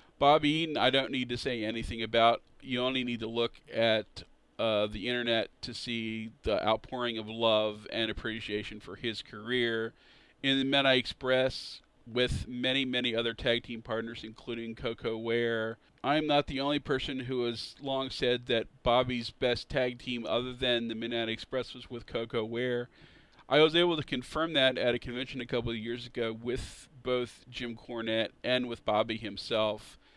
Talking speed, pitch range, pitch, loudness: 175 wpm, 115-125 Hz, 120 Hz, -31 LUFS